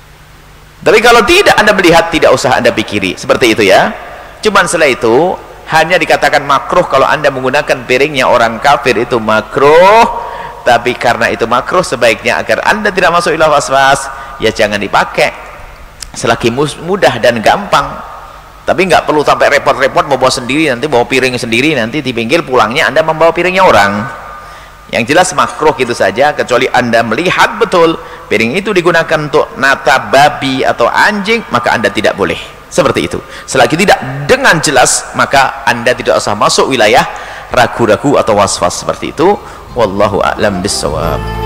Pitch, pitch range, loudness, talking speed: 135 Hz, 110-165 Hz, -9 LUFS, 150 wpm